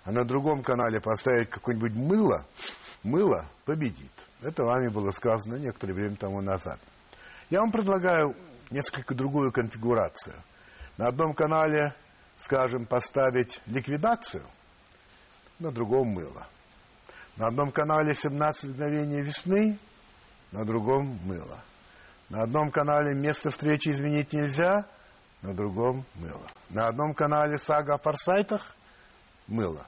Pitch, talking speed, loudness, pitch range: 135 Hz, 115 wpm, -28 LUFS, 115-150 Hz